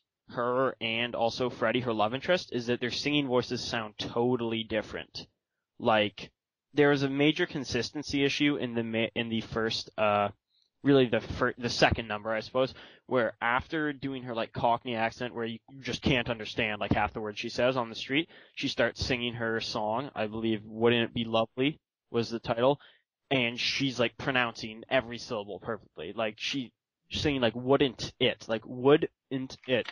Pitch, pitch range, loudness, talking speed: 120 Hz, 115-130 Hz, -30 LUFS, 180 wpm